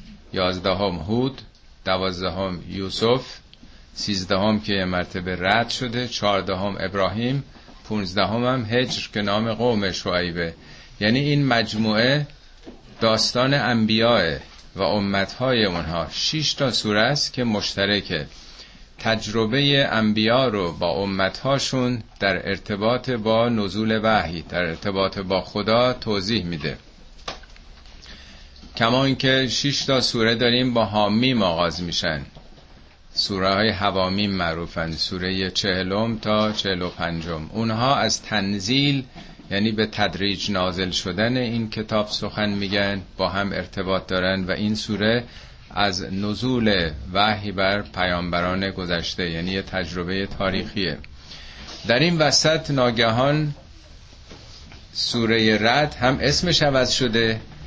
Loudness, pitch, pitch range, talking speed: -22 LUFS, 100 Hz, 90-115 Hz, 110 wpm